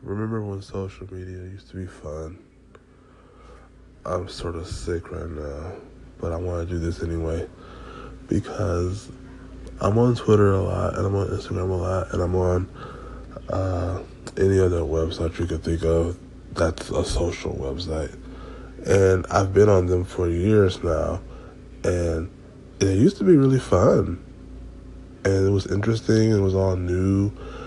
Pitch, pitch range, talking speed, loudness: 95 Hz, 85-100 Hz, 155 wpm, -23 LUFS